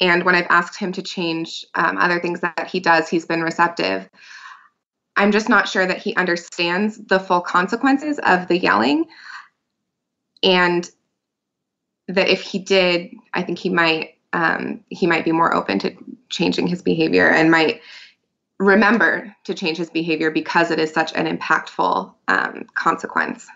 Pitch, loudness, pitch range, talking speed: 175 Hz, -18 LUFS, 165-195 Hz, 160 wpm